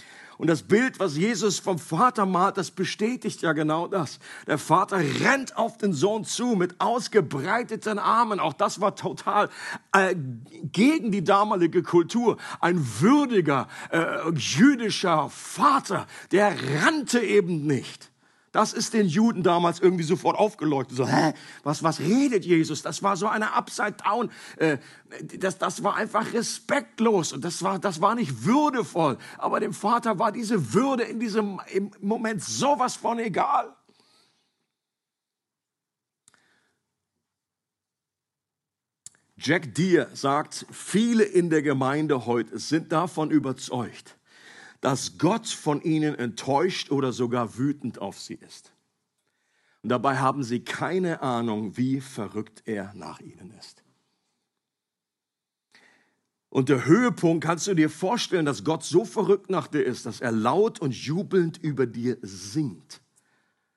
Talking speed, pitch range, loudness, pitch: 135 wpm, 145-210 Hz, -25 LUFS, 175 Hz